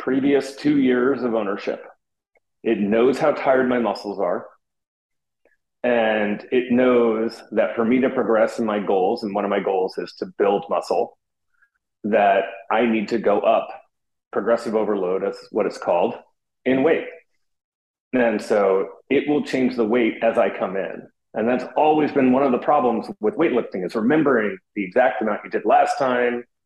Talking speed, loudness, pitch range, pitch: 170 wpm, -21 LUFS, 115-145 Hz, 125 Hz